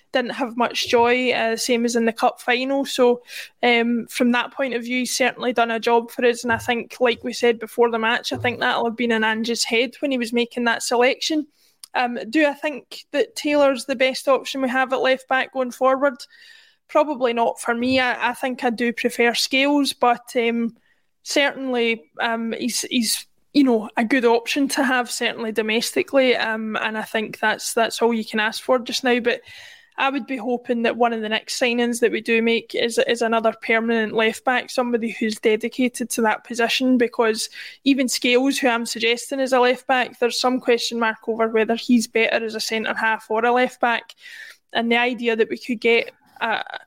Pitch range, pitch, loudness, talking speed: 230-260 Hz, 245 Hz, -20 LUFS, 210 wpm